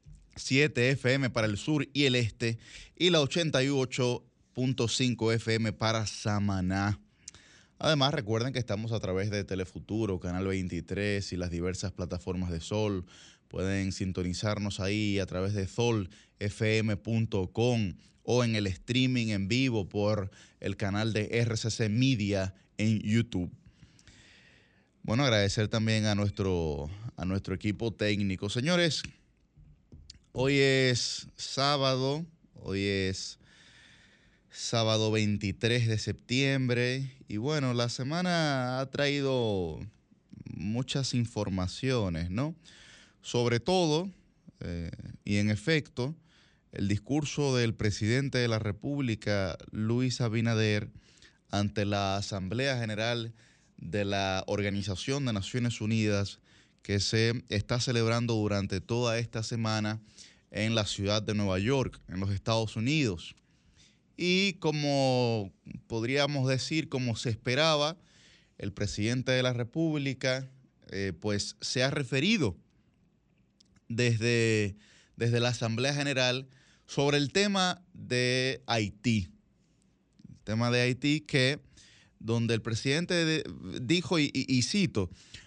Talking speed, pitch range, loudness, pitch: 115 wpm, 100-130 Hz, -30 LUFS, 115 Hz